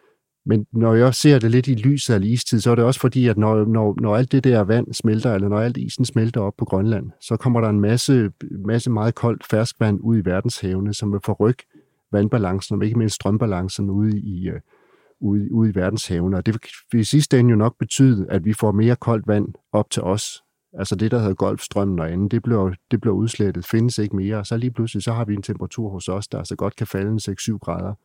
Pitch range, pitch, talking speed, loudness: 100-120 Hz, 110 Hz, 235 wpm, -20 LUFS